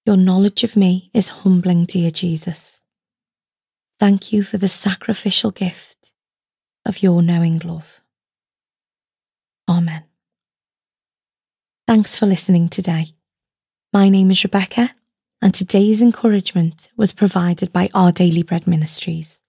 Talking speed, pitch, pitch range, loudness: 115 wpm, 190 Hz, 175-205 Hz, -16 LUFS